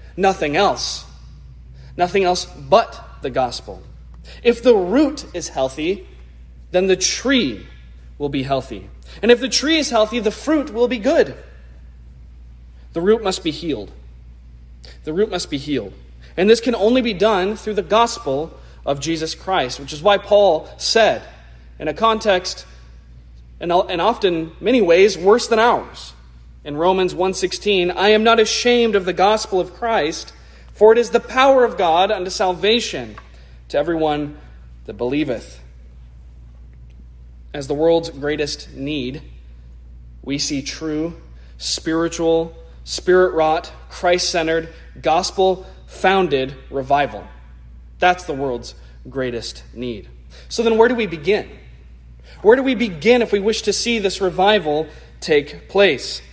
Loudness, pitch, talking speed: -18 LUFS, 160 Hz, 135 wpm